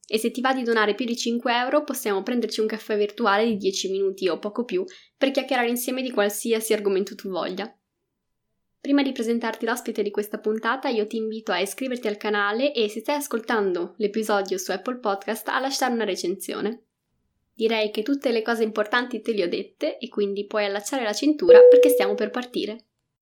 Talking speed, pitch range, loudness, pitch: 195 wpm, 210-255 Hz, -23 LUFS, 225 Hz